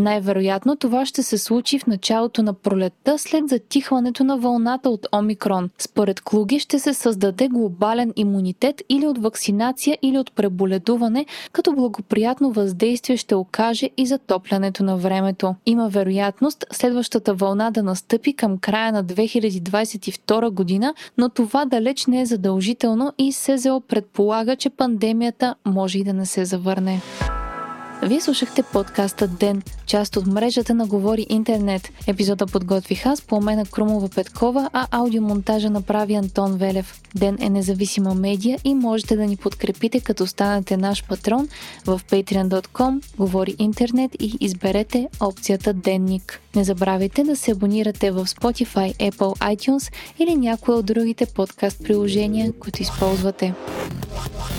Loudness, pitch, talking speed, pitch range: -21 LUFS, 215 Hz, 135 wpm, 195-245 Hz